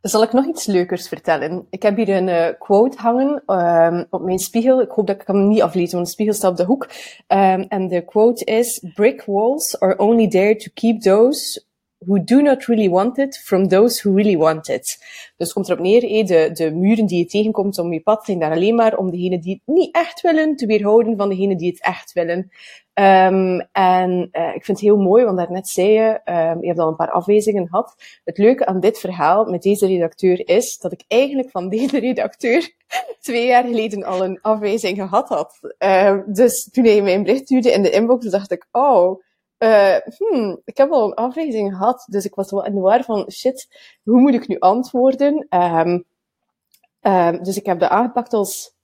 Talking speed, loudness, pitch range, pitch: 215 wpm, -17 LUFS, 185-240 Hz, 205 Hz